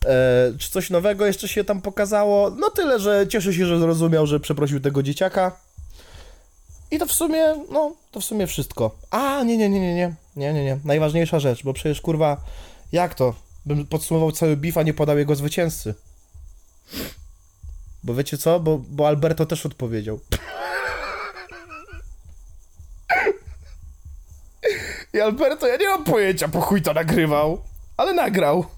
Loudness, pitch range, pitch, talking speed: -21 LUFS, 125-195 Hz, 155 Hz, 150 wpm